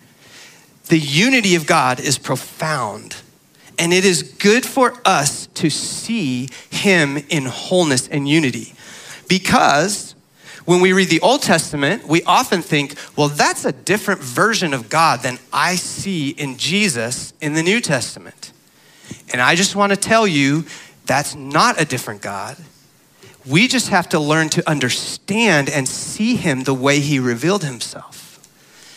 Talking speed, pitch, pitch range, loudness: 150 wpm, 160 Hz, 140-190 Hz, -16 LUFS